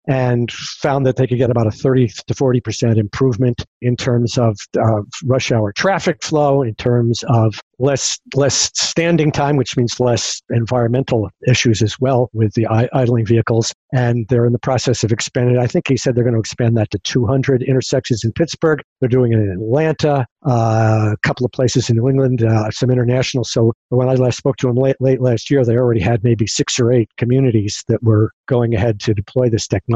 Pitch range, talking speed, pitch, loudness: 115-130 Hz, 210 wpm, 125 Hz, -16 LUFS